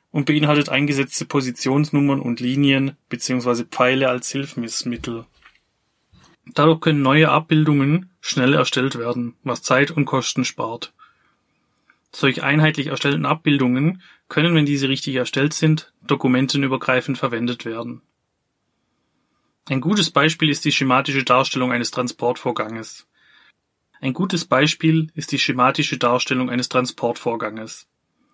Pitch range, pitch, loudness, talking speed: 125-150 Hz, 135 Hz, -19 LUFS, 110 wpm